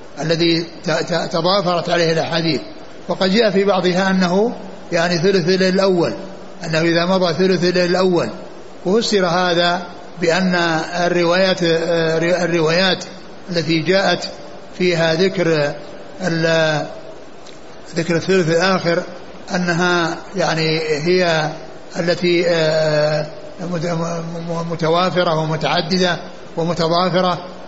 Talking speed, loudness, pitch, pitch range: 80 wpm, -17 LUFS, 175 Hz, 165-185 Hz